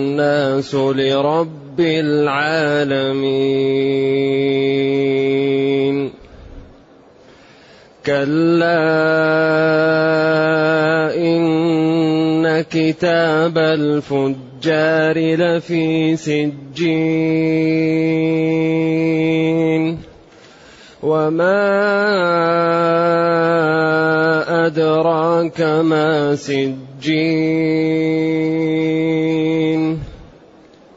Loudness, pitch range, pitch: -16 LUFS, 145-160 Hz, 160 Hz